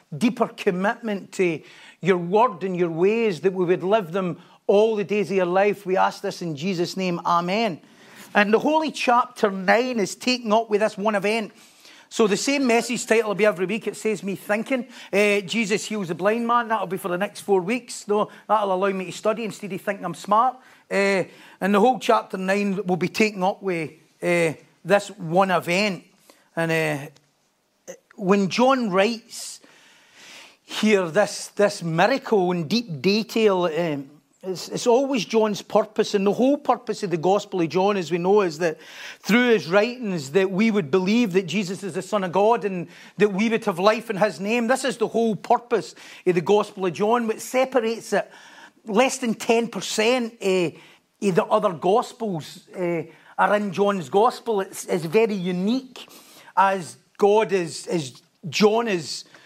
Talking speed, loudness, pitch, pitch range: 180 wpm, -22 LUFS, 205 Hz, 185-225 Hz